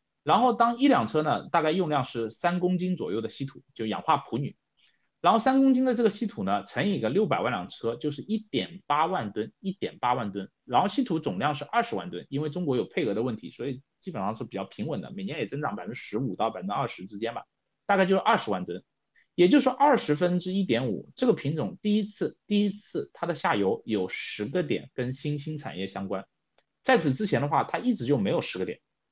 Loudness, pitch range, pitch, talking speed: -28 LUFS, 135-220 Hz, 180 Hz, 340 characters per minute